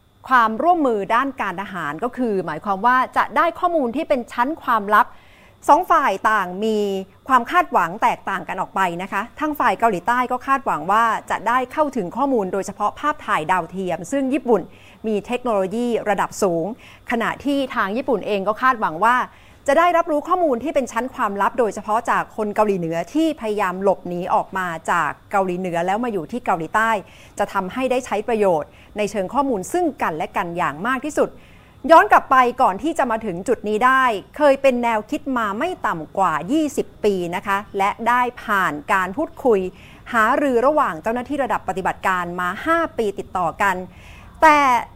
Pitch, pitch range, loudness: 225 Hz, 195-270 Hz, -20 LUFS